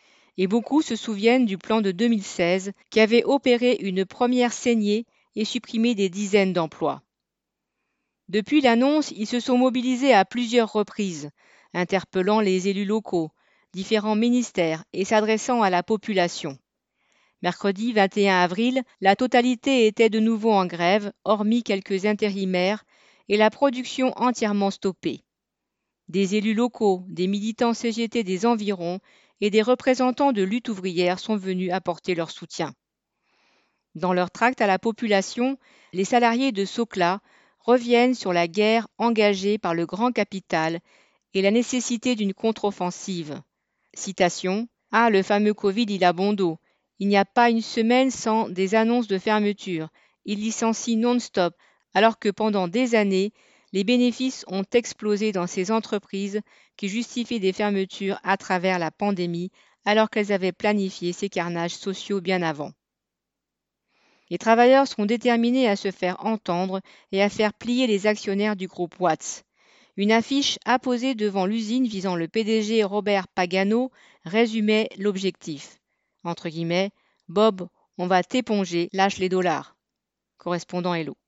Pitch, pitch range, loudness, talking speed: 210 Hz, 190-235 Hz, -23 LUFS, 140 wpm